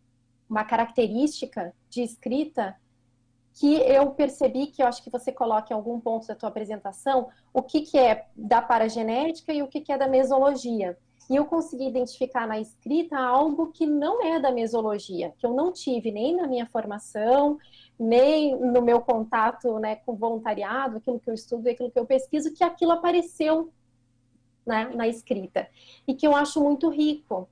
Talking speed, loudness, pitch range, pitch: 175 wpm, -25 LUFS, 220-285 Hz, 245 Hz